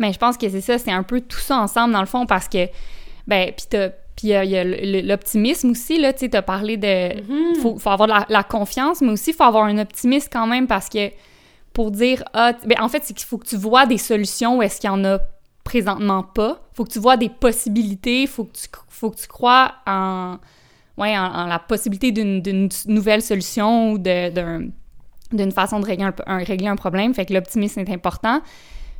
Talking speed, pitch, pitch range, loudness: 225 wpm, 215 Hz, 195-240 Hz, -19 LUFS